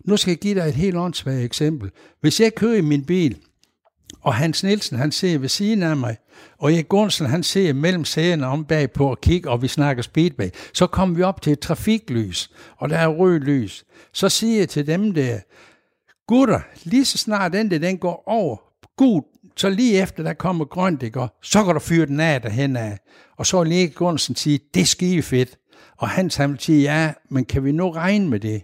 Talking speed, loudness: 220 wpm, -20 LUFS